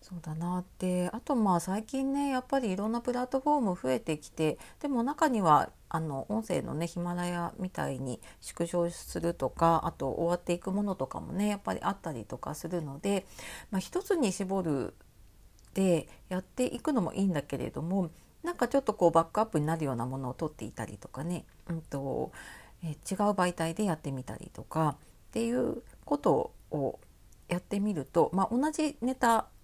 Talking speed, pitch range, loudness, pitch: 365 characters per minute, 155-220 Hz, -32 LUFS, 180 Hz